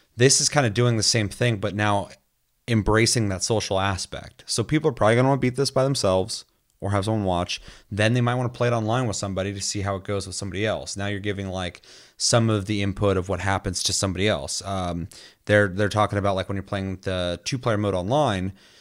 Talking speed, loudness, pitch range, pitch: 245 wpm, -23 LUFS, 95-115 Hz, 100 Hz